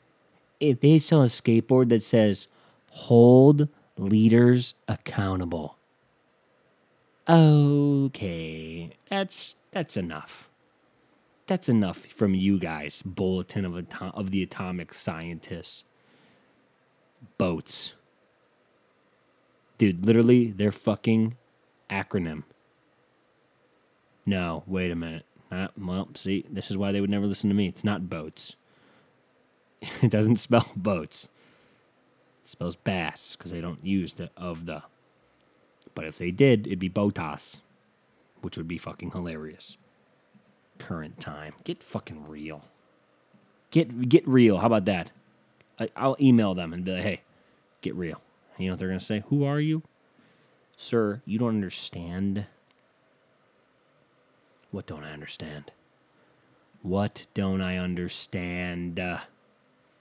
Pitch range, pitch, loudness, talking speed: 90-115 Hz, 100 Hz, -25 LUFS, 120 wpm